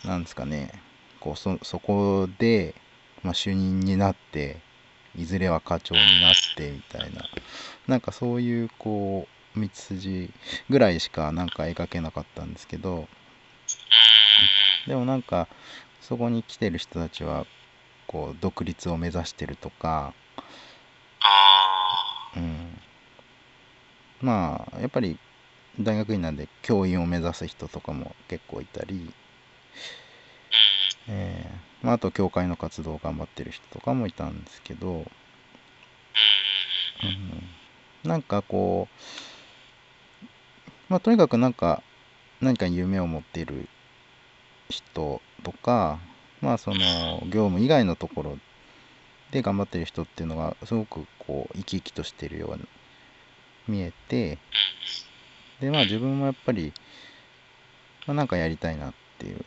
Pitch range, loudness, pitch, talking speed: 85-110 Hz, -23 LUFS, 95 Hz, 240 characters per minute